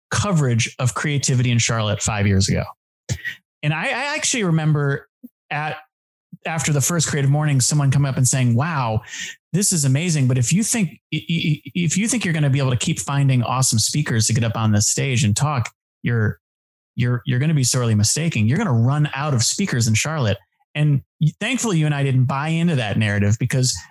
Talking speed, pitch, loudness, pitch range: 205 wpm, 140 Hz, -19 LUFS, 120-155 Hz